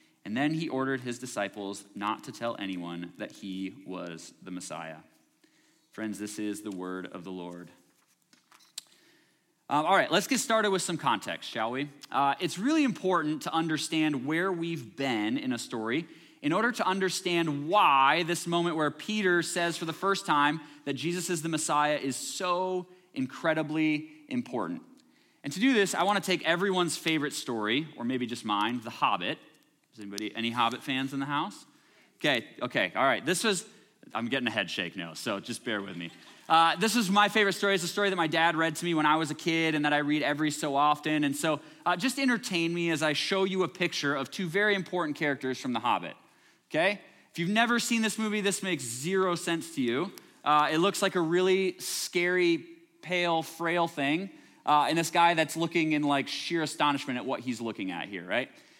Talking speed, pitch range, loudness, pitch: 200 wpm, 135-185 Hz, -29 LUFS, 160 Hz